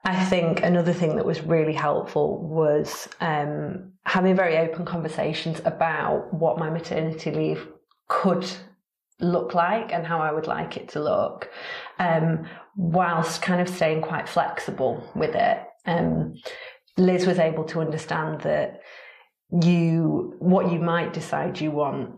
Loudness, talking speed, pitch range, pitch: -24 LUFS, 145 wpm, 160-180 Hz, 165 Hz